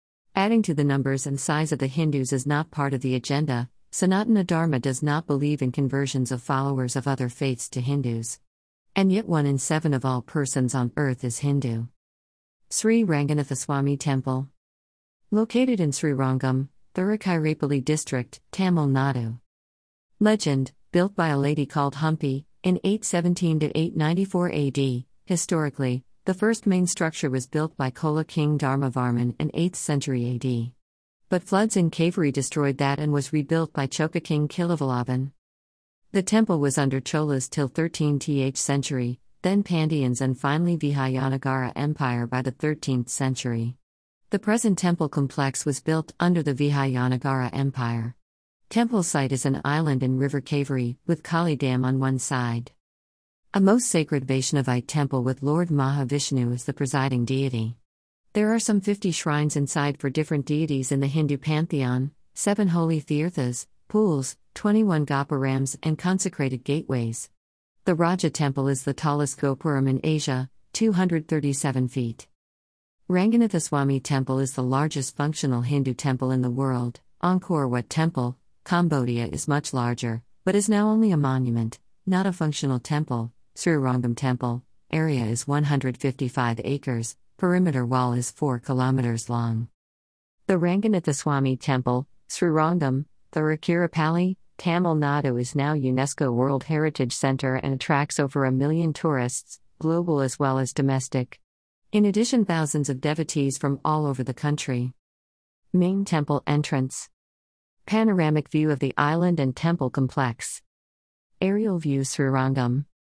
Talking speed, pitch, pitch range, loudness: 140 wpm, 140 Hz, 130-160 Hz, -25 LUFS